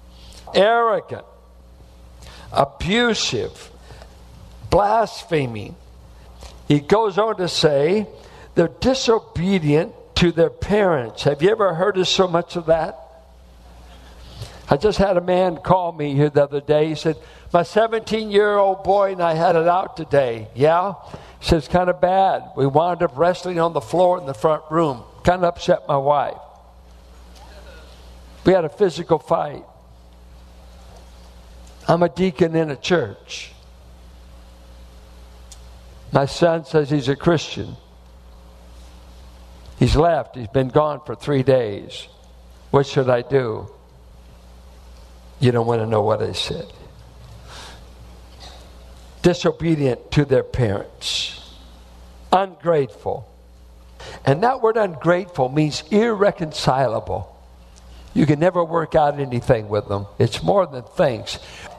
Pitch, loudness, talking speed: 135 Hz, -19 LUFS, 125 wpm